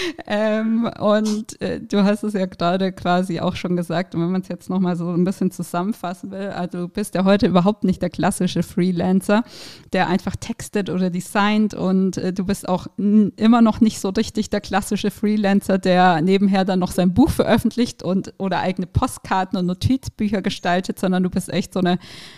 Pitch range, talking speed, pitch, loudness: 180-210 Hz, 195 wpm, 190 Hz, -20 LUFS